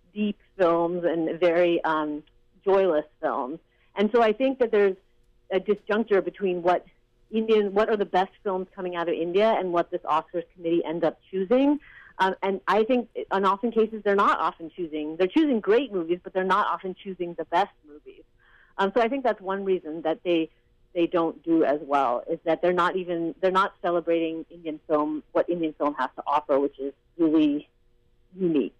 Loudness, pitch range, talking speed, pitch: -25 LUFS, 160-195 Hz, 190 wpm, 175 Hz